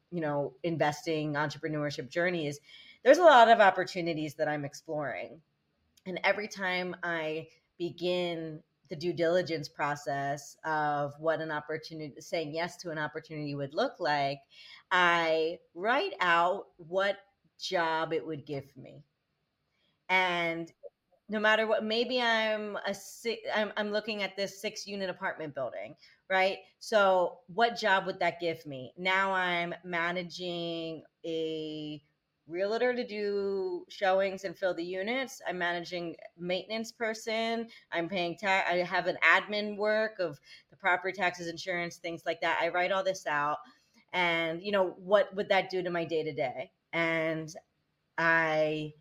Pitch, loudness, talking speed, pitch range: 175 Hz, -30 LUFS, 145 wpm, 160-195 Hz